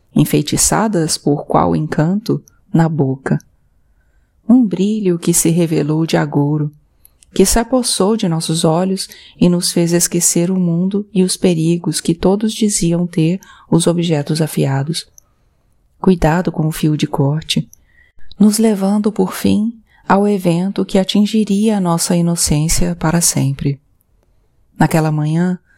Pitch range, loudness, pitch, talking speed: 155-190 Hz, -15 LUFS, 170 Hz, 130 wpm